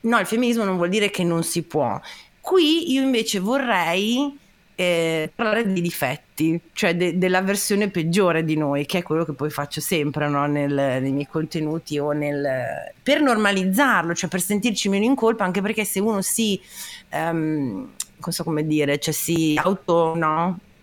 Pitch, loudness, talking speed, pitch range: 180 Hz, -22 LUFS, 175 wpm, 155-210 Hz